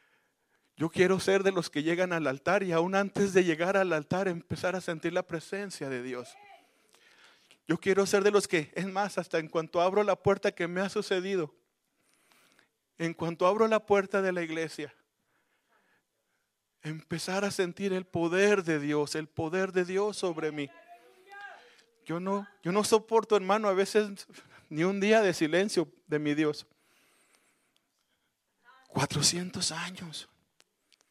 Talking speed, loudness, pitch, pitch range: 155 wpm, -29 LUFS, 185 Hz, 165-200 Hz